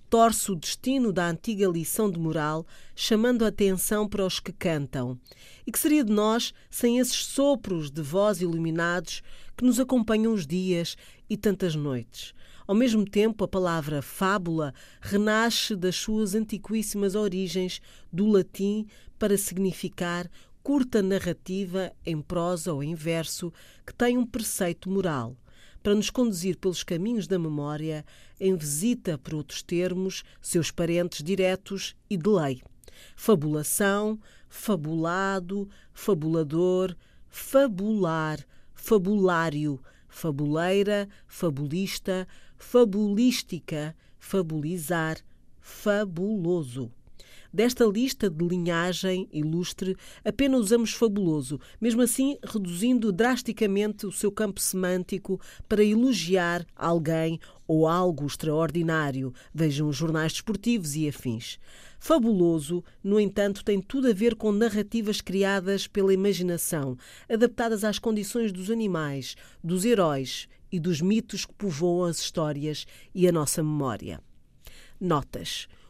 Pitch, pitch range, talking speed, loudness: 185 Hz, 165-210 Hz, 115 wpm, -27 LUFS